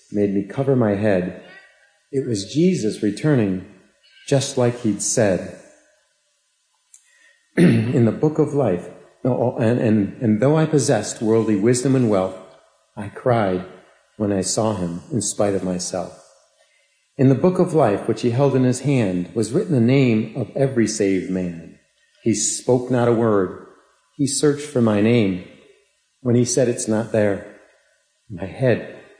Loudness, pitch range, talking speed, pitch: -20 LUFS, 100-135 Hz, 155 wpm, 115 Hz